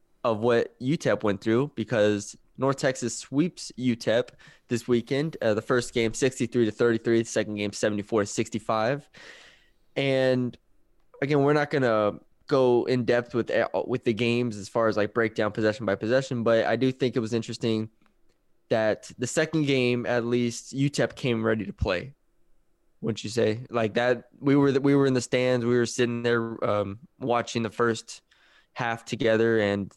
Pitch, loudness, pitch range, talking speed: 120 Hz, -26 LUFS, 110-130 Hz, 175 wpm